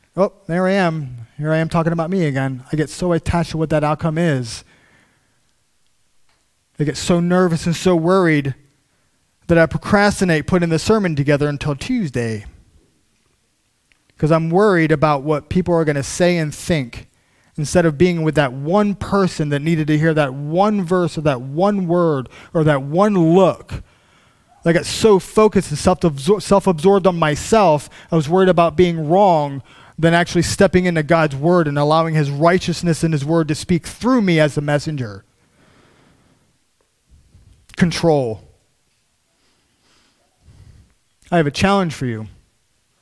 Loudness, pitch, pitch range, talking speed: -17 LUFS, 165 Hz, 145-180 Hz, 160 wpm